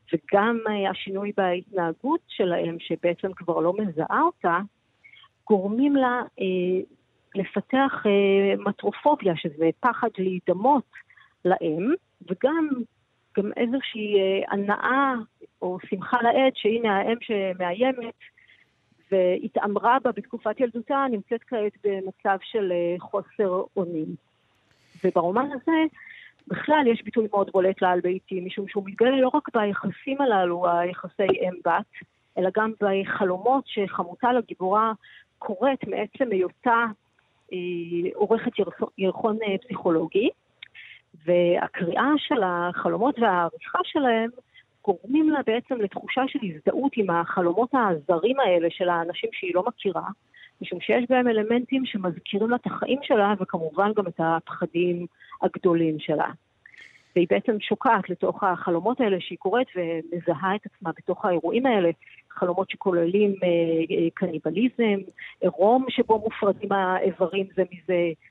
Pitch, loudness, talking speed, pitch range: 200 Hz, -25 LUFS, 115 wpm, 180-235 Hz